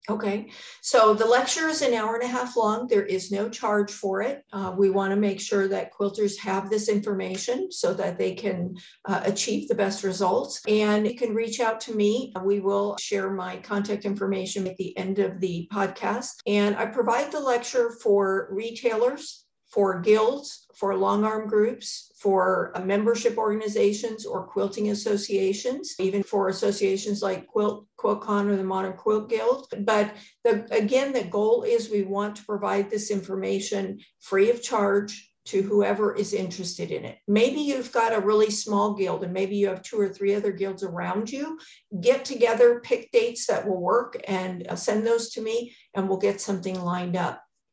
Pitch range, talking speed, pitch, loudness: 195-230 Hz, 180 wpm, 210 Hz, -25 LUFS